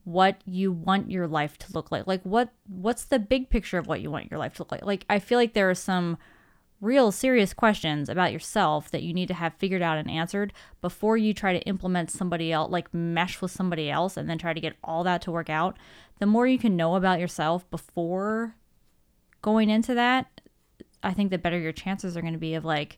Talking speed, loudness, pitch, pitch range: 230 wpm, -26 LUFS, 185 Hz, 165-205 Hz